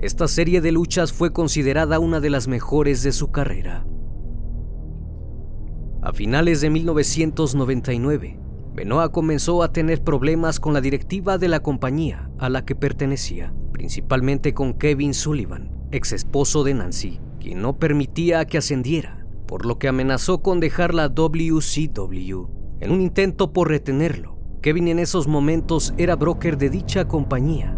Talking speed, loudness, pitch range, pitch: 145 wpm, -21 LUFS, 115-160 Hz, 145 Hz